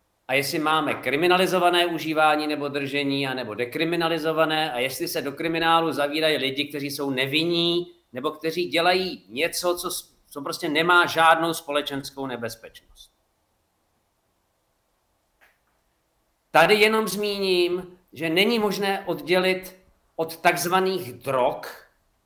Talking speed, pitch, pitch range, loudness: 110 wpm, 165 Hz, 145-180 Hz, -23 LUFS